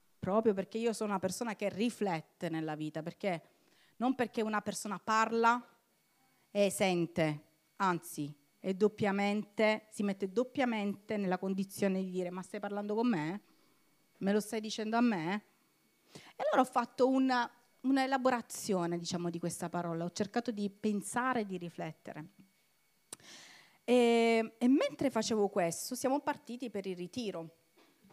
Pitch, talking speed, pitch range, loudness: 205 Hz, 135 wpm, 185-235 Hz, -34 LUFS